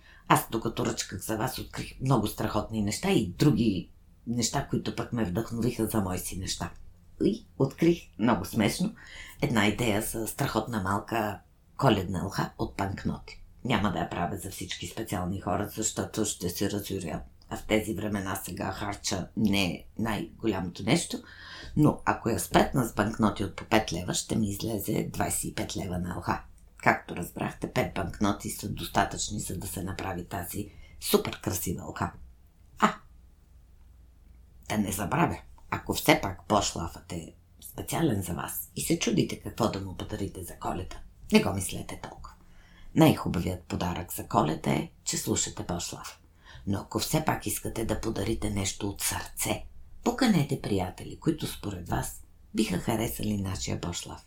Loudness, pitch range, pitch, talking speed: -30 LUFS, 85-110 Hz, 100 Hz, 150 wpm